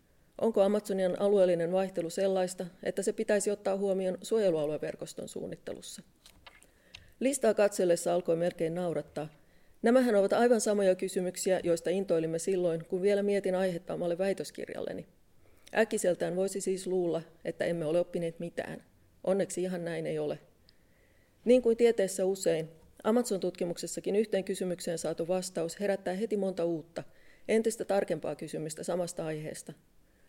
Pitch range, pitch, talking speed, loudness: 170-200 Hz, 185 Hz, 125 wpm, -31 LUFS